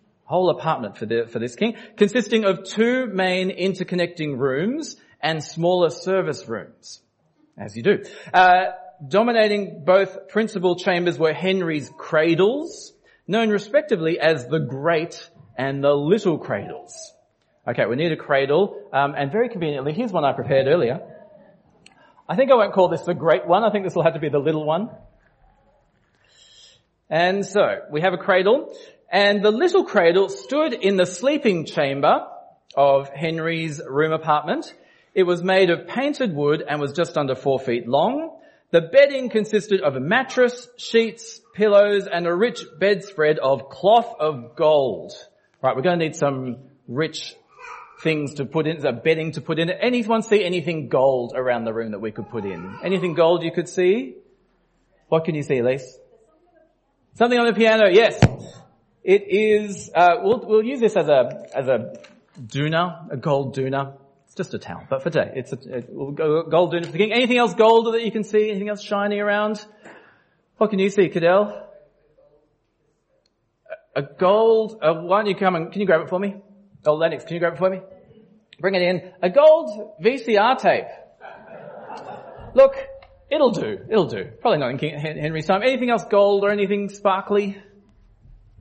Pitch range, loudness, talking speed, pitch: 155-215 Hz, -20 LUFS, 175 wpm, 185 Hz